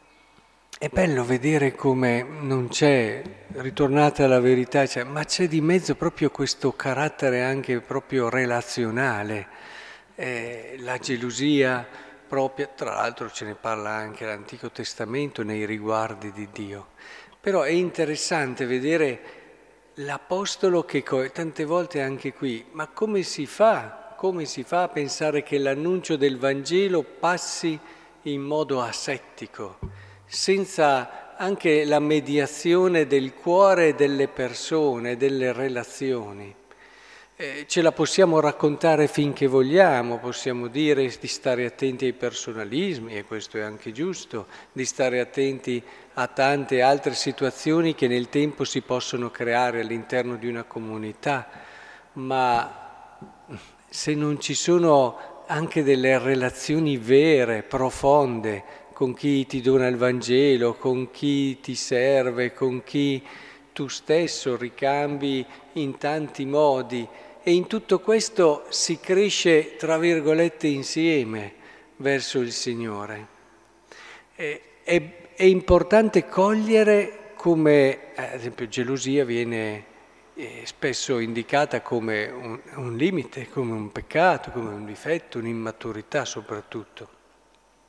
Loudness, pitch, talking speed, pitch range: -23 LUFS, 135 Hz, 115 wpm, 125-155 Hz